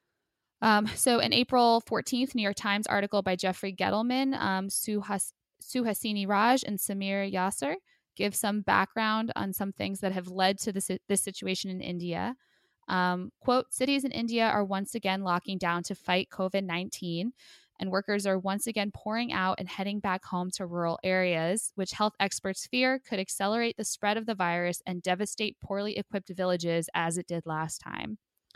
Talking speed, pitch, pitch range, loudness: 175 wpm, 195 Hz, 185-220 Hz, -30 LUFS